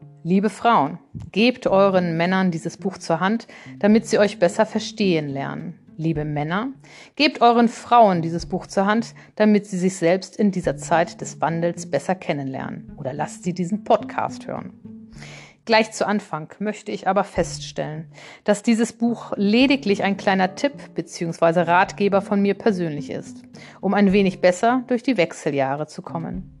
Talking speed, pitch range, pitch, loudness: 160 wpm, 170-220 Hz, 195 Hz, -21 LUFS